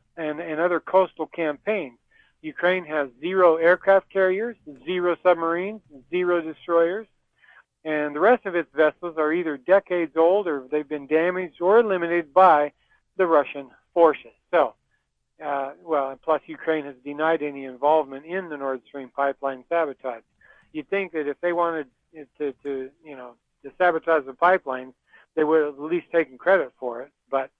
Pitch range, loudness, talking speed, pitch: 140-175 Hz, -23 LUFS, 160 wpm, 160 Hz